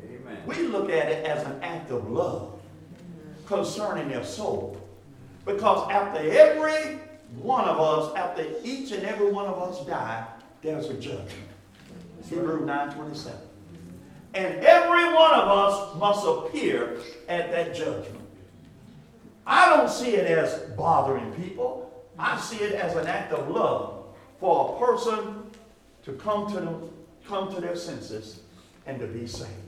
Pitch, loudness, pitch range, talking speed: 175 Hz, -25 LUFS, 130-210 Hz, 145 wpm